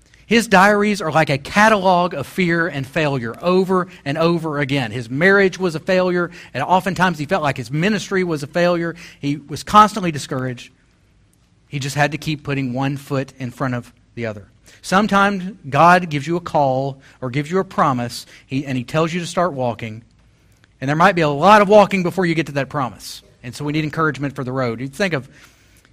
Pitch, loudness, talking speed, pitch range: 145 Hz, -18 LUFS, 210 wpm, 130-180 Hz